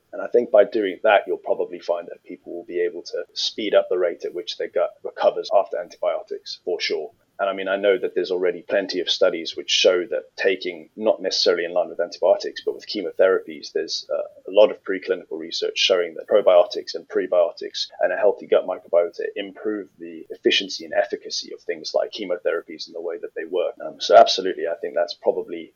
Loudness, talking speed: -22 LUFS, 205 wpm